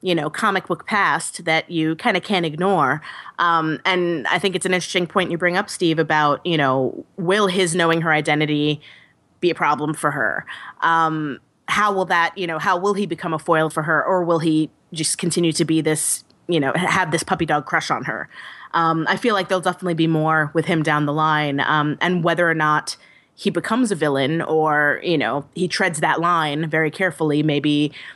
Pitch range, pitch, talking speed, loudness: 155-180 Hz, 165 Hz, 210 wpm, -19 LUFS